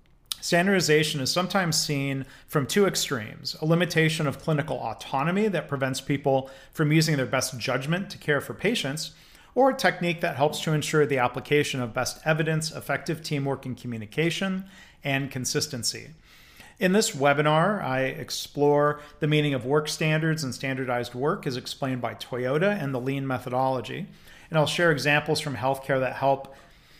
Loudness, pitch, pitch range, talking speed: -26 LUFS, 145 Hz, 130-160 Hz, 160 wpm